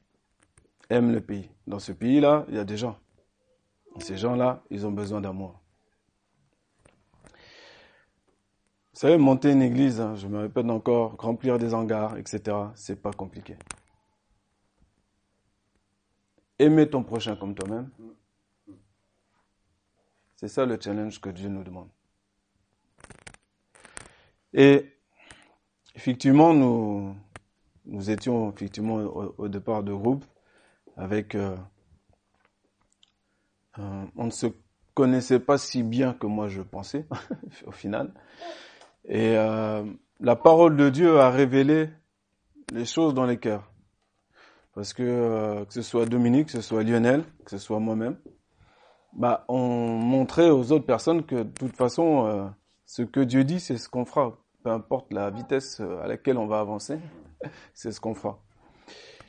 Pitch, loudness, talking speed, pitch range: 110 Hz, -24 LUFS, 135 wpm, 100-125 Hz